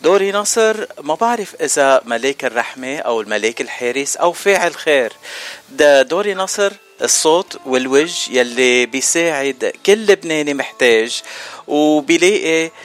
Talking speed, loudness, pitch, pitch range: 110 wpm, -15 LUFS, 155 Hz, 130-200 Hz